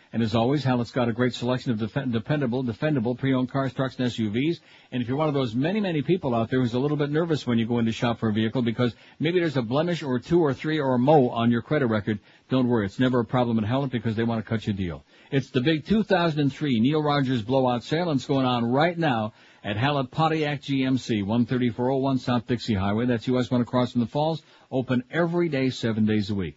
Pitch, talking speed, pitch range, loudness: 125 Hz, 245 wpm, 120-145 Hz, -25 LUFS